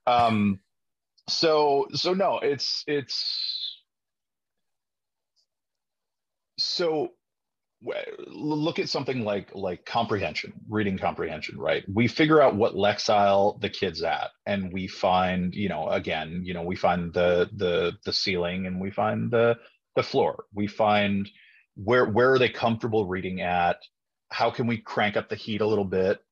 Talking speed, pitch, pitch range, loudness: 145 wpm, 105 Hz, 95-125 Hz, -26 LUFS